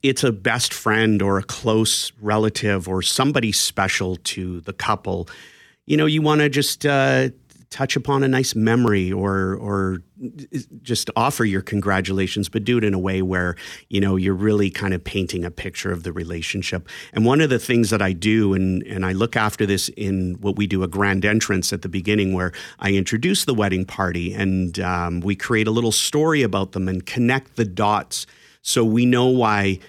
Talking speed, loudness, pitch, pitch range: 195 wpm, -20 LUFS, 100 Hz, 95-115 Hz